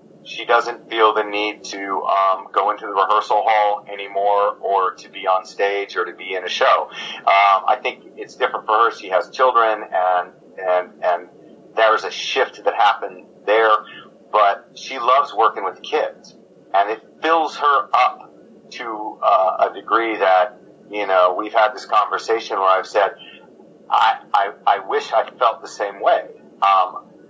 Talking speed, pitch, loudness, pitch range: 170 wpm, 100 Hz, -18 LUFS, 95-110 Hz